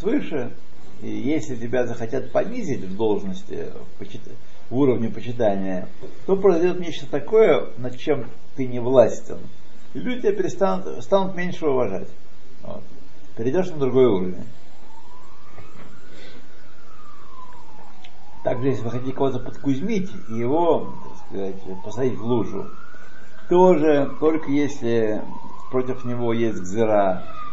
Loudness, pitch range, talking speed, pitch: -23 LUFS, 115-180 Hz, 115 wpm, 130 Hz